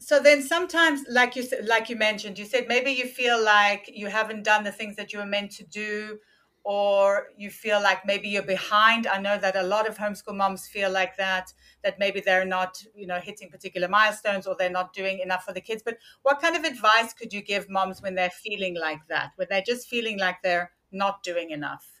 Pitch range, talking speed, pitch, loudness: 190-225 Hz, 225 wpm, 205 Hz, -25 LUFS